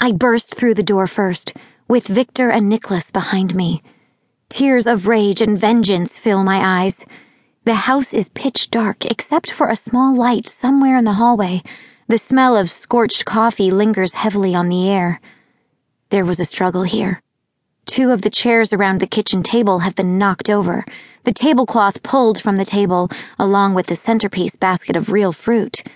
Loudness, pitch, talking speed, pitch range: -16 LUFS, 210 Hz, 175 wpm, 190-235 Hz